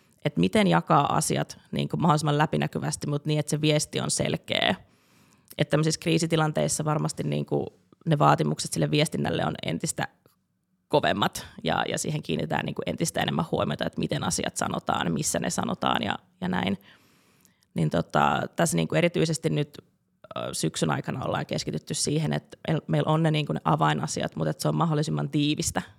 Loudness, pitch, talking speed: -26 LUFS, 150 Hz, 155 wpm